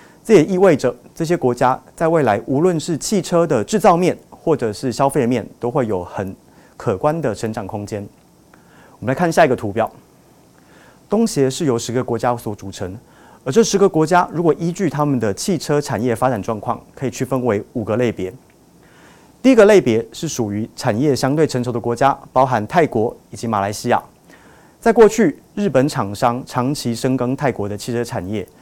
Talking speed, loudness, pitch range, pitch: 280 characters per minute, -18 LUFS, 115-165 Hz, 130 Hz